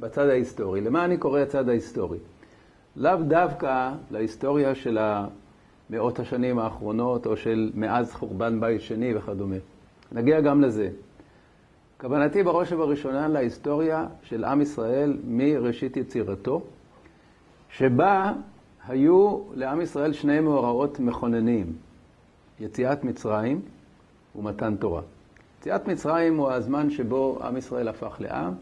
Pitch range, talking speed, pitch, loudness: 110-145 Hz, 110 wpm, 125 Hz, -25 LUFS